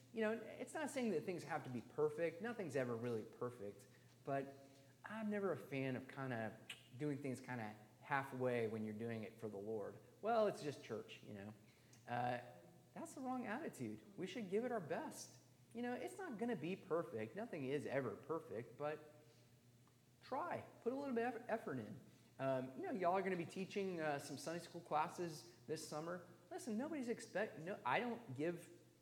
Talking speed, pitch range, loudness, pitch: 200 wpm, 125-205 Hz, -46 LUFS, 150 Hz